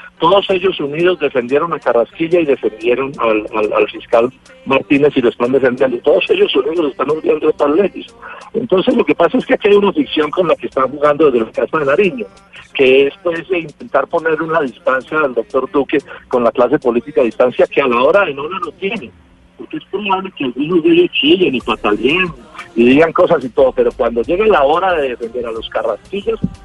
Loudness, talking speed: -14 LUFS, 215 wpm